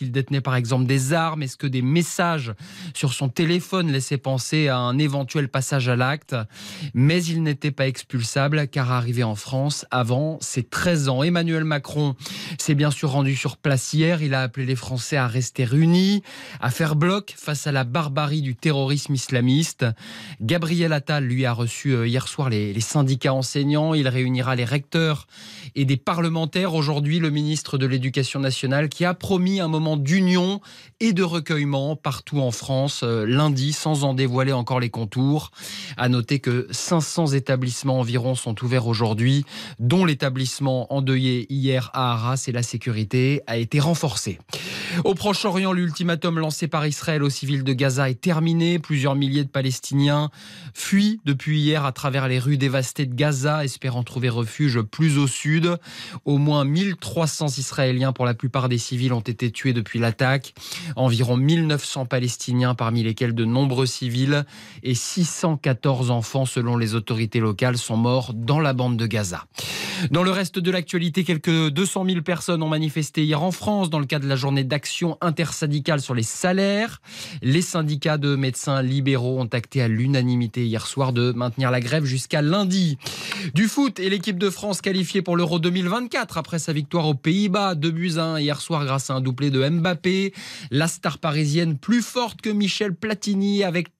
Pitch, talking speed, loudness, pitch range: 140 Hz, 170 wpm, -22 LUFS, 130-165 Hz